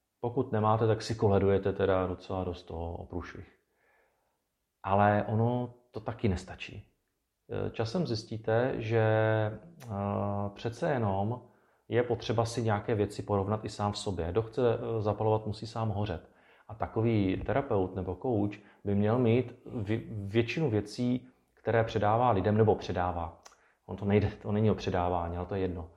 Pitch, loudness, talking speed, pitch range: 105 Hz, -31 LUFS, 145 wpm, 100-115 Hz